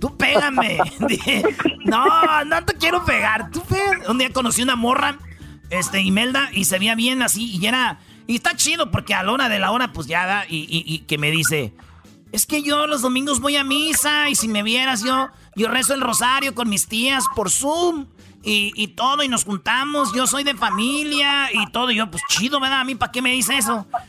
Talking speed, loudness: 220 wpm, -18 LUFS